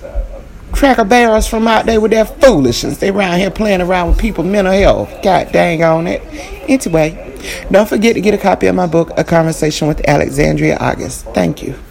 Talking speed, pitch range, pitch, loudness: 190 wpm, 165-225 Hz, 195 Hz, -12 LUFS